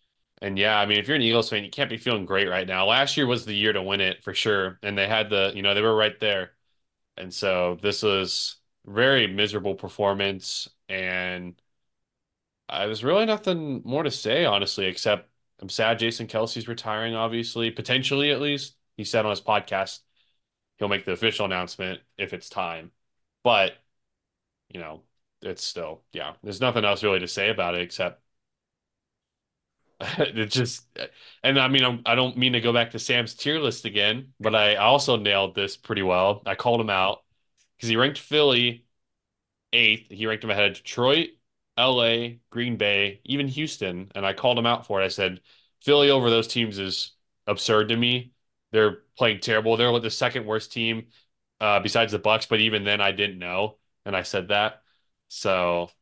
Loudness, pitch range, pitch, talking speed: -24 LUFS, 100-120 Hz, 110 Hz, 185 wpm